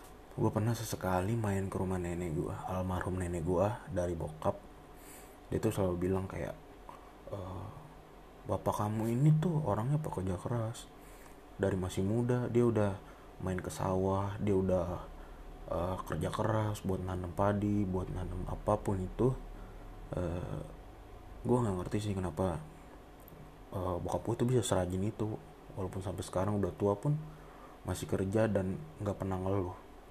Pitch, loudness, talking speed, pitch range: 95 Hz, -35 LUFS, 145 wpm, 90-110 Hz